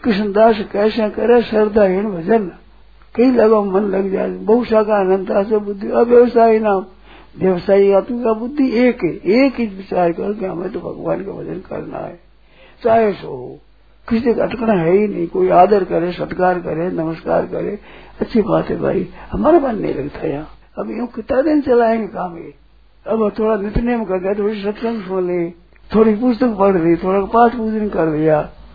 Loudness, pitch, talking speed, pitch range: -16 LUFS, 210 Hz, 175 wpm, 190-230 Hz